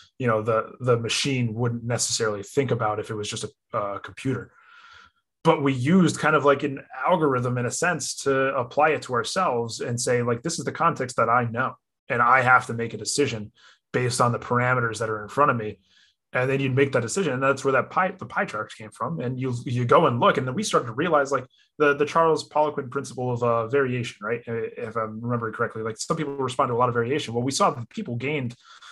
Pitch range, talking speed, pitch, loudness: 115-145 Hz, 240 wpm, 125 Hz, -24 LUFS